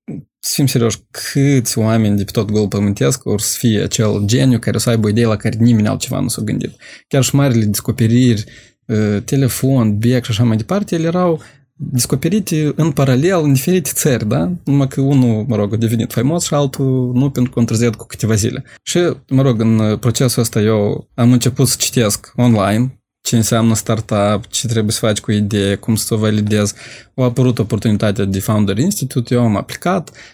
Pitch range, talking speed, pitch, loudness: 110-135 Hz, 190 wpm, 120 Hz, -15 LUFS